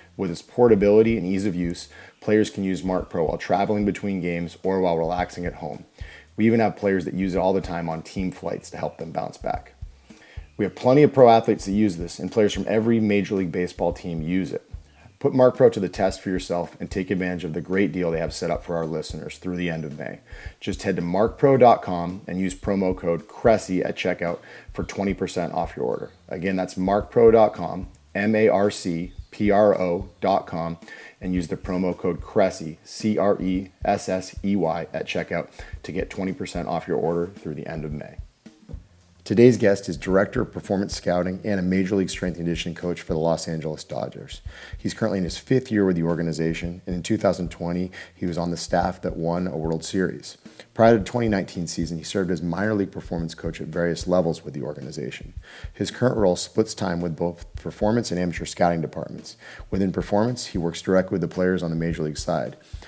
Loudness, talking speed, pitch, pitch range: -23 LUFS, 210 wpm, 90 Hz, 85-100 Hz